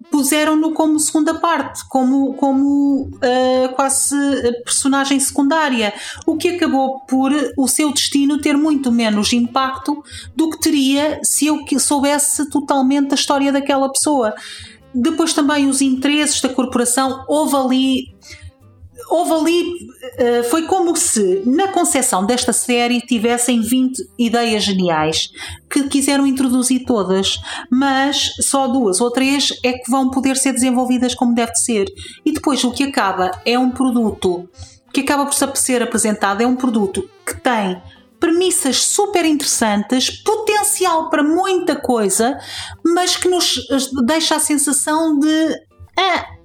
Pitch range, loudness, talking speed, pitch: 245-300 Hz, -16 LUFS, 135 wpm, 270 Hz